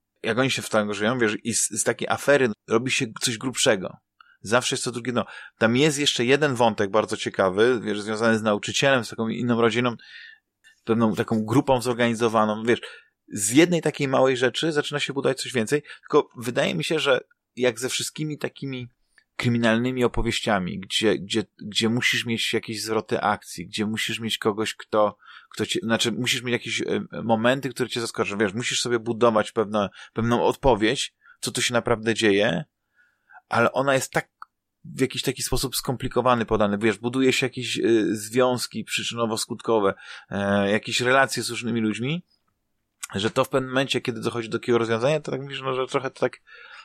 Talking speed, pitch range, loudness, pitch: 175 wpm, 110-130 Hz, -23 LUFS, 120 Hz